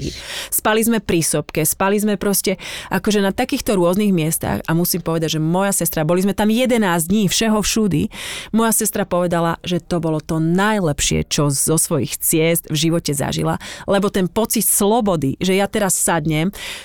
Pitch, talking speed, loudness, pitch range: 180 Hz, 170 wpm, -18 LUFS, 165-210 Hz